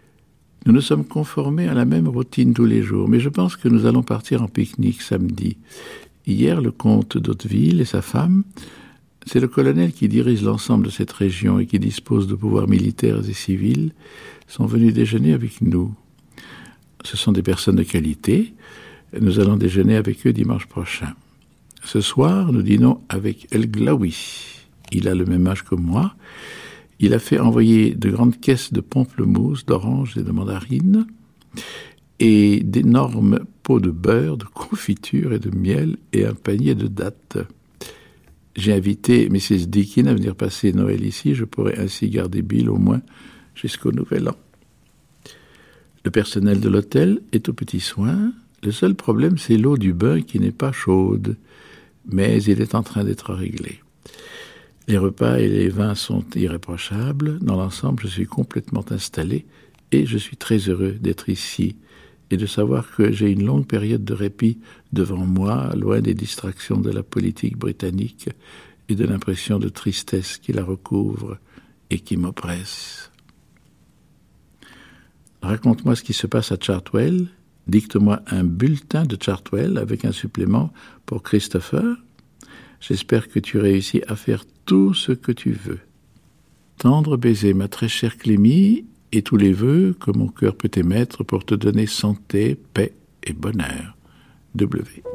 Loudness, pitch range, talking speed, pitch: -19 LUFS, 95-120 Hz, 160 wpm, 110 Hz